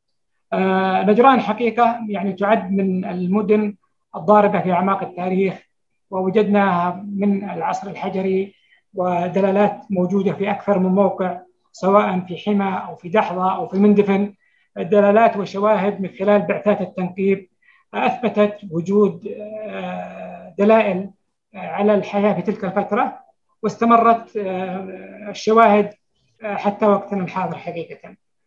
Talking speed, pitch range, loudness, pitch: 105 wpm, 190-210 Hz, -19 LUFS, 200 Hz